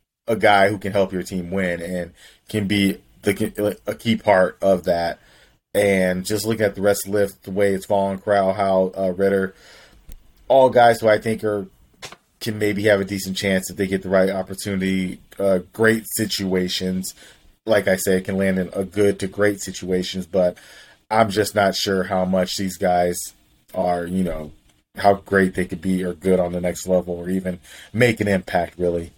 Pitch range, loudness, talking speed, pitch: 90-100 Hz, -20 LUFS, 195 wpm, 95 Hz